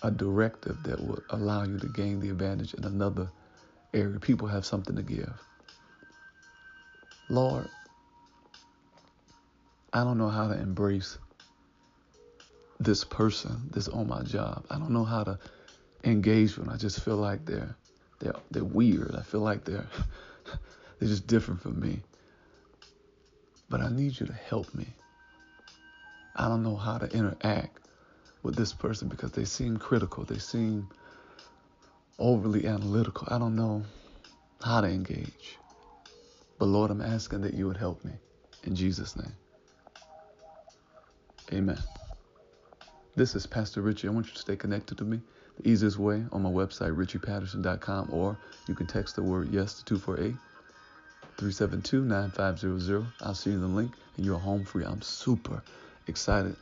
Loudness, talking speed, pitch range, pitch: -31 LUFS, 145 wpm, 100-115 Hz, 105 Hz